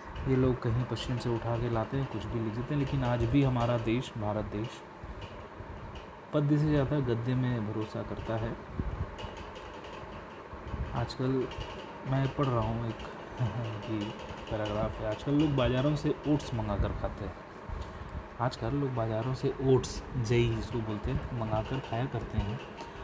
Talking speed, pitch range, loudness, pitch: 155 wpm, 110-130 Hz, -32 LUFS, 115 Hz